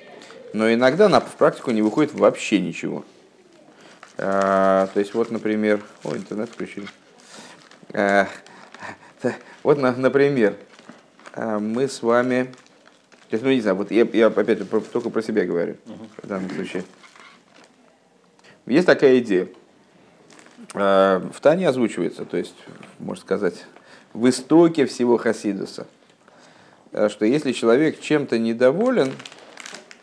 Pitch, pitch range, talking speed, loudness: 115 Hz, 105-130 Hz, 105 wpm, -20 LUFS